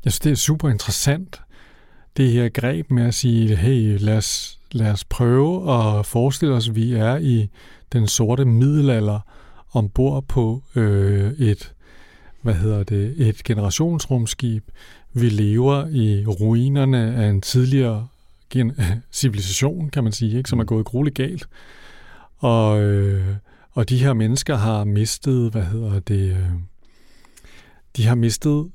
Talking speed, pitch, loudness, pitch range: 140 wpm, 115 Hz, -20 LUFS, 105-130 Hz